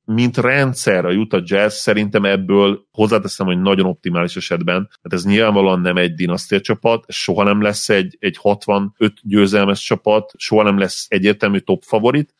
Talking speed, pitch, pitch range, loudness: 160 wpm, 100 Hz, 95-110 Hz, -16 LUFS